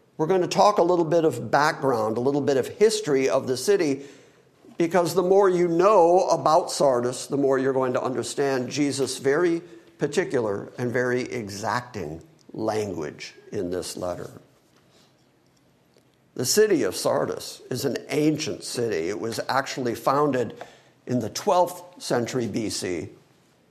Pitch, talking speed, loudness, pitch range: 145 Hz, 145 wpm, -24 LUFS, 130-180 Hz